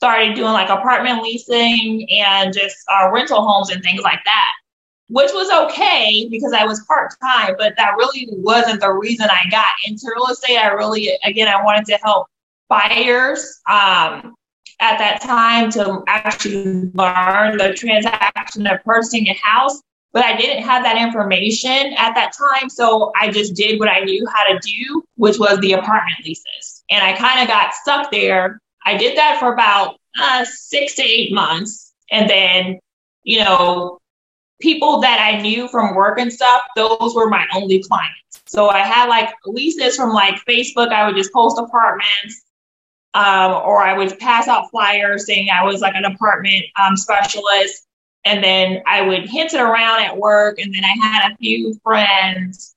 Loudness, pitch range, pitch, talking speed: -14 LUFS, 195-240 Hz, 215 Hz, 175 wpm